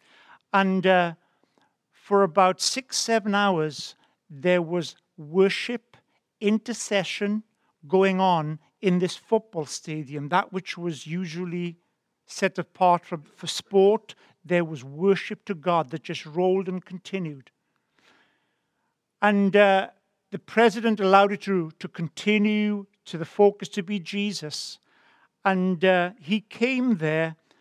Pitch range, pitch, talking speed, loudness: 170-205 Hz, 185 Hz, 120 wpm, -24 LUFS